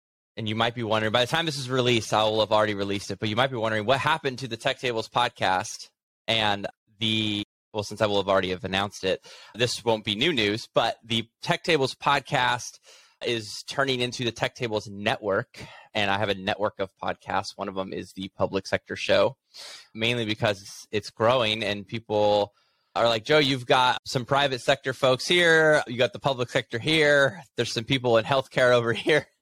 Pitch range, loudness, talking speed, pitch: 105-130 Hz, -25 LUFS, 205 wpm, 115 Hz